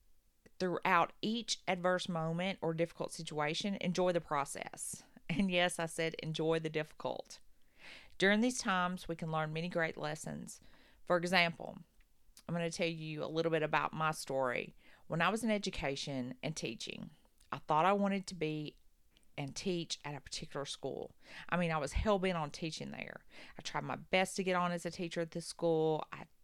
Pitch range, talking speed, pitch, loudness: 155-180 Hz, 185 wpm, 170 Hz, -36 LUFS